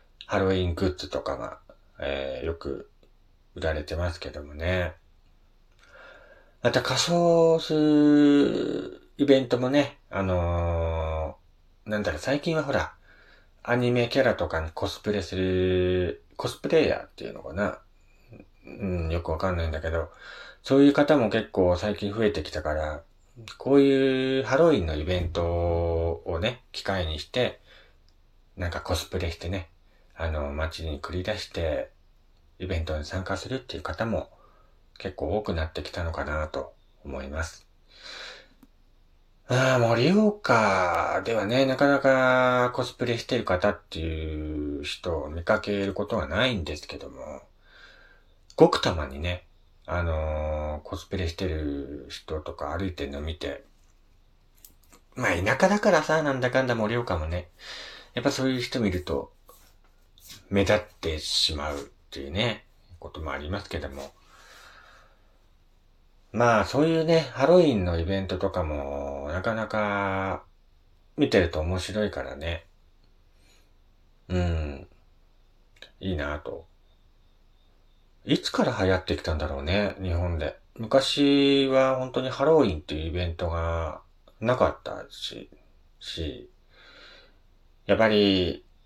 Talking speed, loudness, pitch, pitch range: 260 characters per minute, -26 LUFS, 90 Hz, 80-105 Hz